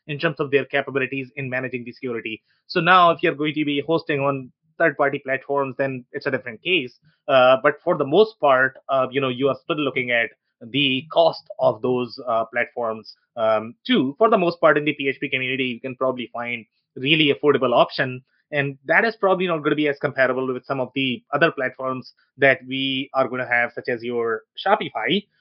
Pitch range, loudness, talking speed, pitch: 130-150 Hz, -21 LUFS, 210 wpm, 135 Hz